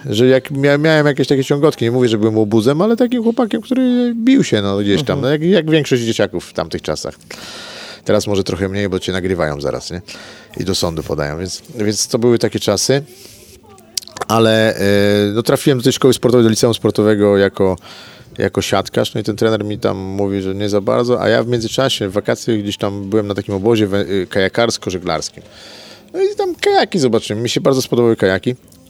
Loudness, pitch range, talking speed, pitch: -15 LUFS, 100-135 Hz, 200 wpm, 115 Hz